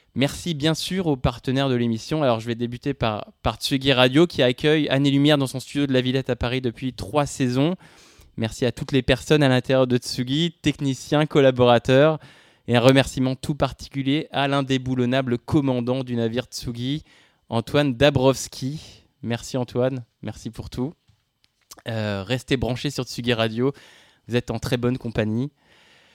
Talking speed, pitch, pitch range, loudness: 165 wpm, 130 Hz, 120-140 Hz, -22 LUFS